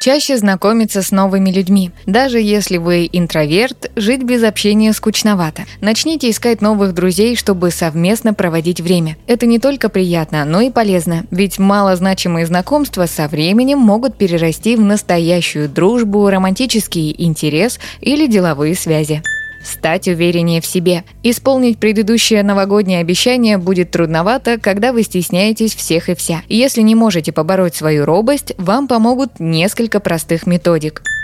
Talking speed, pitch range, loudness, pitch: 135 wpm, 175-225 Hz, -13 LUFS, 195 Hz